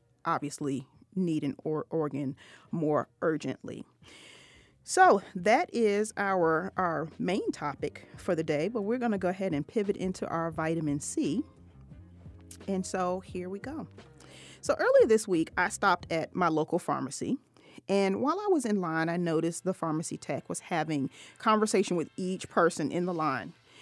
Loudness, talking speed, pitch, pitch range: -30 LUFS, 160 wpm, 170 Hz, 150-200 Hz